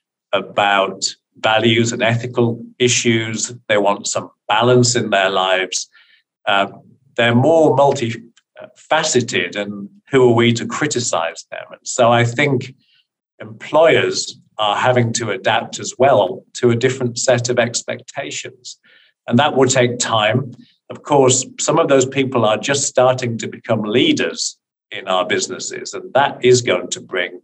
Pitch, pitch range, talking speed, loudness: 120 Hz, 115-130 Hz, 145 wpm, -16 LUFS